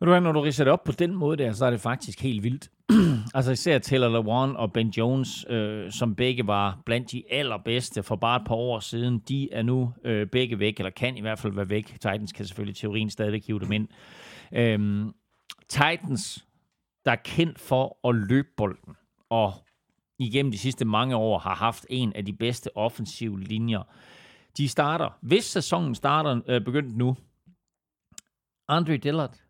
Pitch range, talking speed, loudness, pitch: 110-135 Hz, 180 wpm, -26 LUFS, 120 Hz